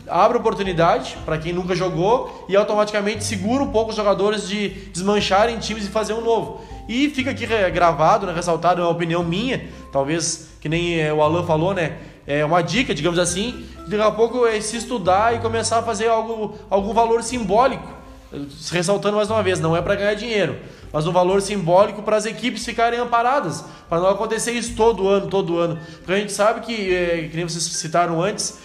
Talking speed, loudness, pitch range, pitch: 195 wpm, -20 LUFS, 170-225 Hz, 200 Hz